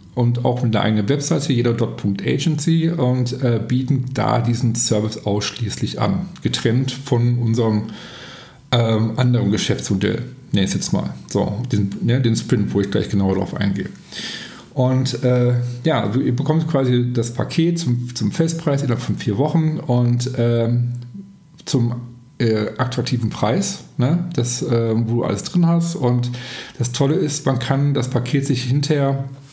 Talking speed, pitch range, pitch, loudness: 150 wpm, 115-135 Hz, 125 Hz, -19 LUFS